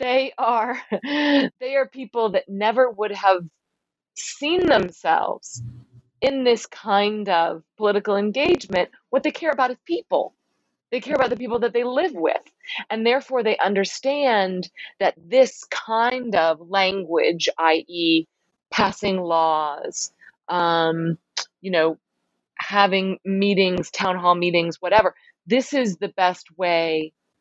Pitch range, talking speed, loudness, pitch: 170-255 Hz, 125 wpm, -21 LUFS, 200 Hz